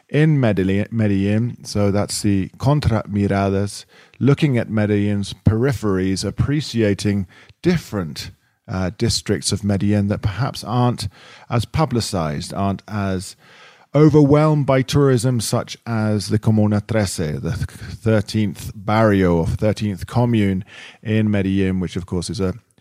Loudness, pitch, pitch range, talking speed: -19 LUFS, 105 Hz, 100-120 Hz, 120 wpm